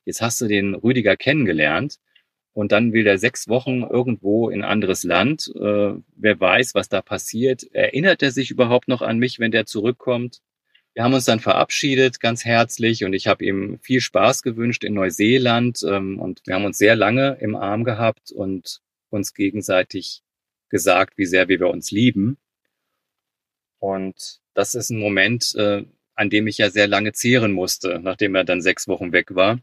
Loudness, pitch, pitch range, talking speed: -19 LUFS, 110 Hz, 100-125 Hz, 180 wpm